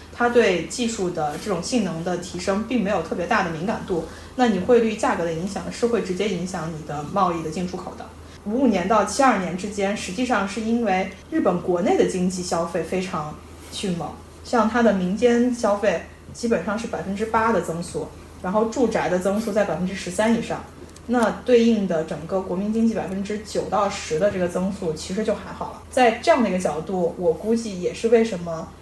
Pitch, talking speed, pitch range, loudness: 200 Hz, 310 characters per minute, 180-225 Hz, -23 LUFS